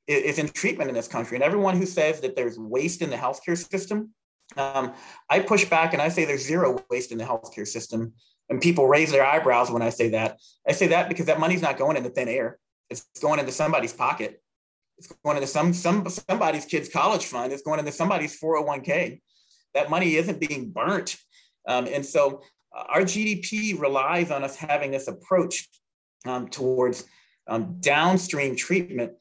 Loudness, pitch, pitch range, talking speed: -24 LUFS, 155 Hz, 135-180 Hz, 190 wpm